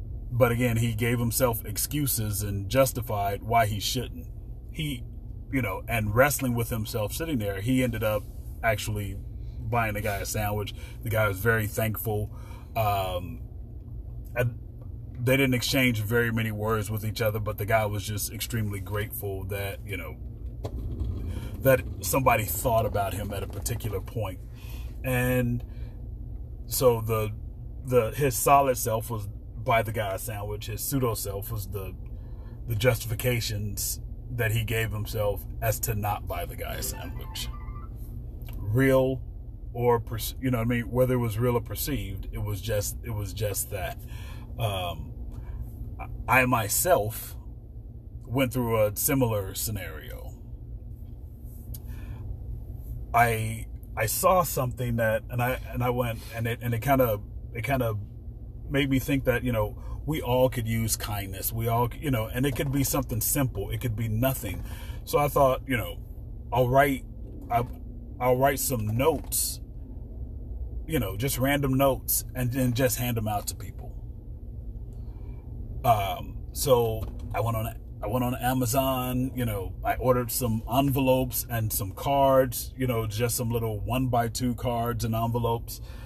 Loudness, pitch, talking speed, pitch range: -27 LUFS, 115 Hz, 155 wpm, 105-125 Hz